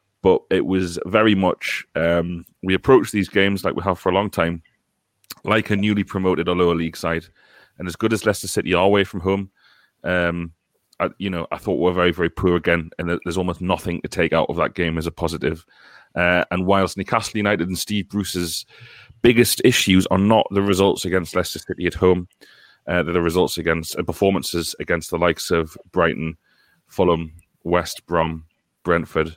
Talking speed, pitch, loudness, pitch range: 190 wpm, 90 Hz, -20 LUFS, 85-100 Hz